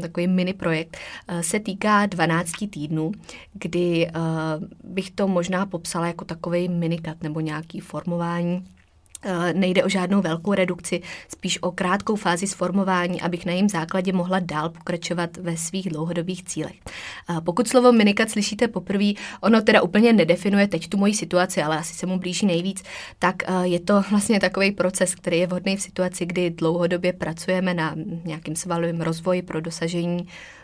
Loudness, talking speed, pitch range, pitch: -23 LUFS, 155 wpm, 170-195 Hz, 180 Hz